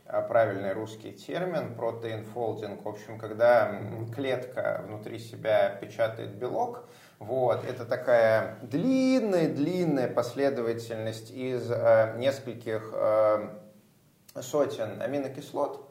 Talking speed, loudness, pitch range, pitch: 85 wpm, -28 LUFS, 110-130 Hz, 115 Hz